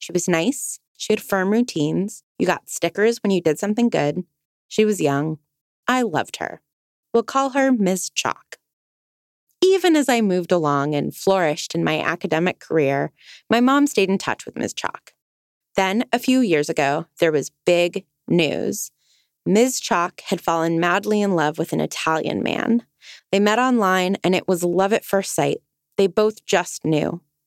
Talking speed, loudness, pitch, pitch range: 175 wpm, -20 LUFS, 190 Hz, 165-225 Hz